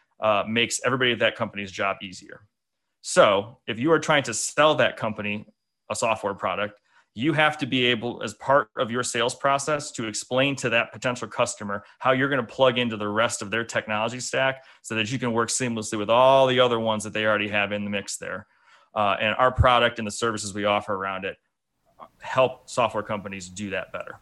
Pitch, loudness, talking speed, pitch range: 115 Hz, -24 LUFS, 210 wpm, 105-130 Hz